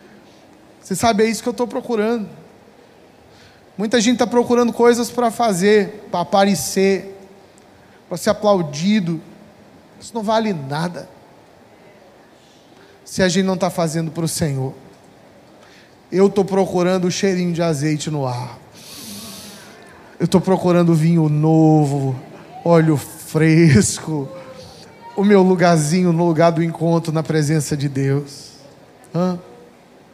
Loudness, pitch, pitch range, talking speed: -17 LUFS, 175 Hz, 160-200 Hz, 125 wpm